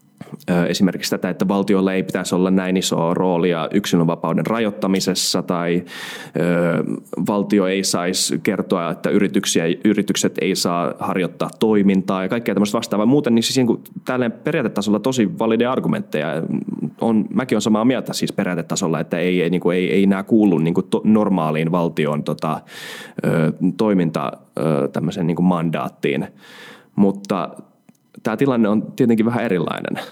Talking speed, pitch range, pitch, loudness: 140 wpm, 90-105 Hz, 95 Hz, -19 LUFS